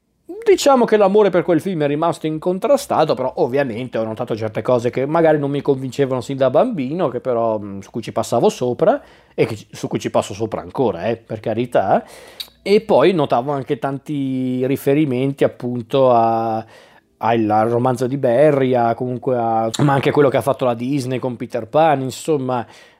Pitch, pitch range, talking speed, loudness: 130 Hz, 120-145 Hz, 180 wpm, -18 LUFS